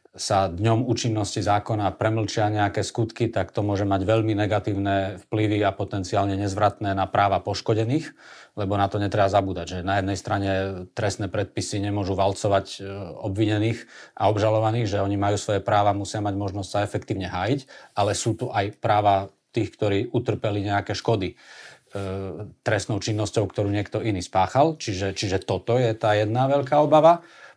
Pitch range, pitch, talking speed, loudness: 100-110 Hz, 105 Hz, 155 wpm, -24 LUFS